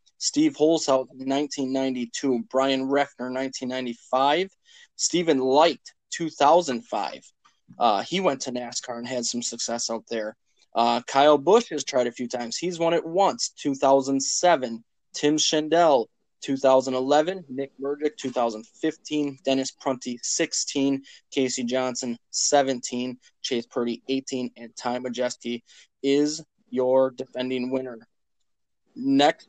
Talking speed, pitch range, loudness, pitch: 140 wpm, 125-150 Hz, -24 LUFS, 130 Hz